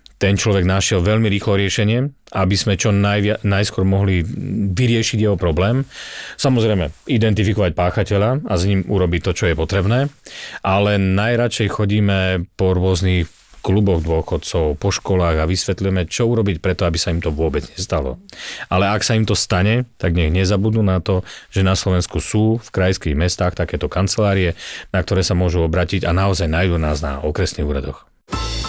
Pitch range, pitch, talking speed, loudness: 90-105 Hz, 95 Hz, 160 wpm, -18 LUFS